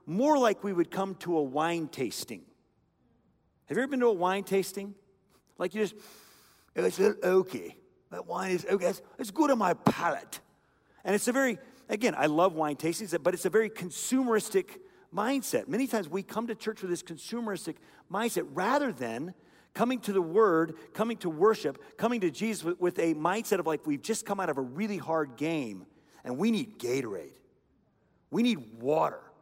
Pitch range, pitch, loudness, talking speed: 170-225 Hz, 200 Hz, -30 LUFS, 190 wpm